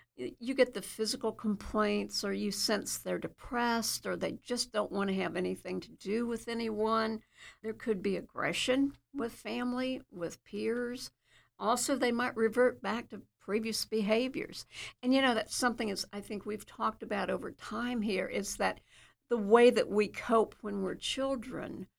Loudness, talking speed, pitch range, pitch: -33 LUFS, 170 wpm, 210-245 Hz, 225 Hz